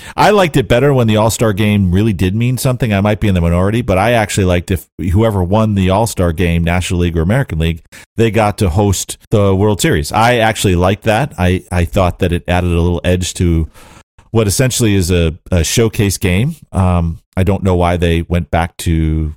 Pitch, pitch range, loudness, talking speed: 95 Hz, 85-110 Hz, -13 LUFS, 215 wpm